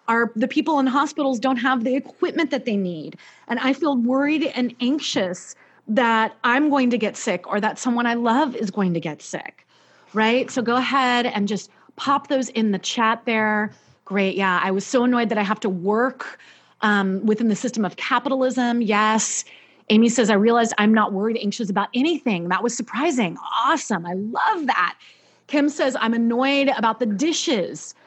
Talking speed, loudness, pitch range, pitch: 190 wpm, -21 LUFS, 215-265 Hz, 235 Hz